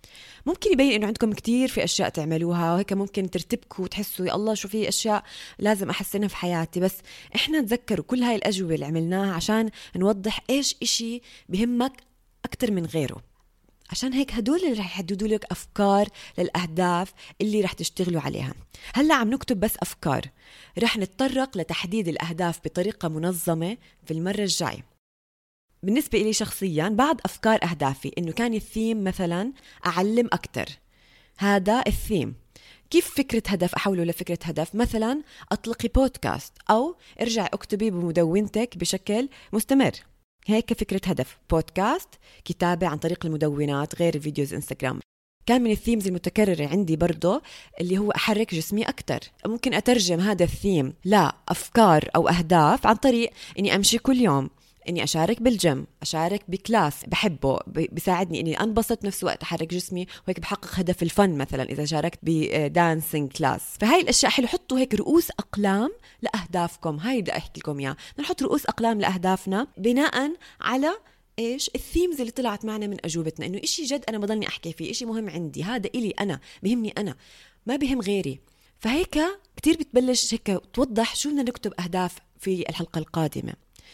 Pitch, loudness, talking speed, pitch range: 200 Hz, -25 LUFS, 145 wpm, 170-230 Hz